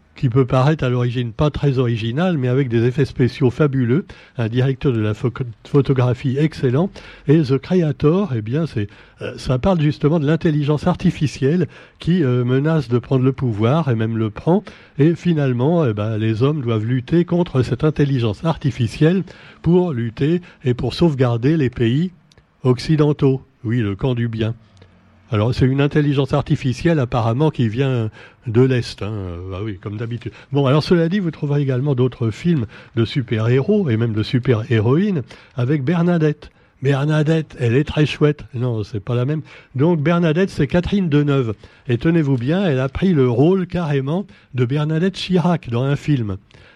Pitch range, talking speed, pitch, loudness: 120-155 Hz, 170 wpm, 135 Hz, -18 LUFS